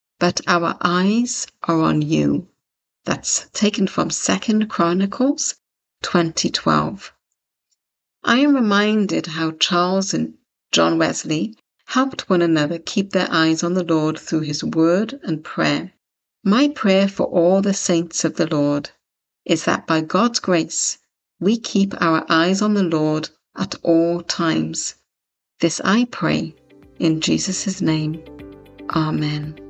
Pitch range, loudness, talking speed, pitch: 160-200 Hz, -19 LUFS, 135 wpm, 170 Hz